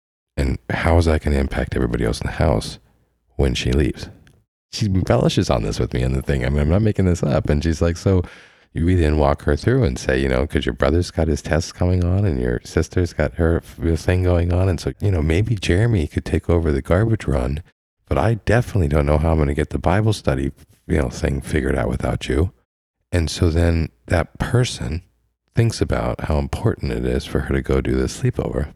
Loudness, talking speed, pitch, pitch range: -20 LUFS, 230 wpm, 80 Hz, 70-90 Hz